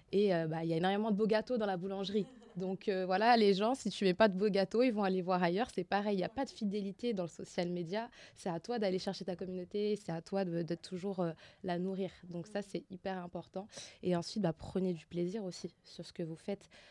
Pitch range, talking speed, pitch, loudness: 180-210 Hz, 270 wpm, 190 Hz, -36 LUFS